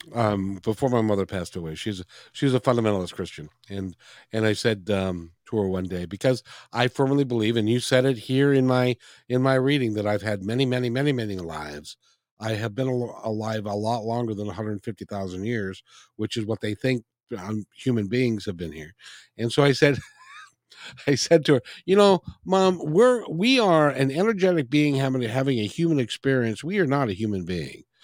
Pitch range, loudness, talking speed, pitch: 105-135 Hz, -24 LUFS, 195 wpm, 115 Hz